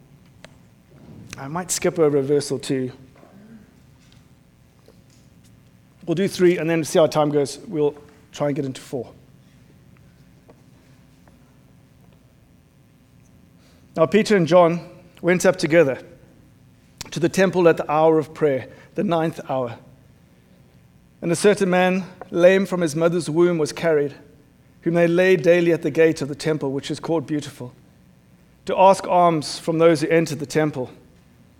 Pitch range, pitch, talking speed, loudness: 145-175 Hz, 160 Hz, 140 wpm, -20 LUFS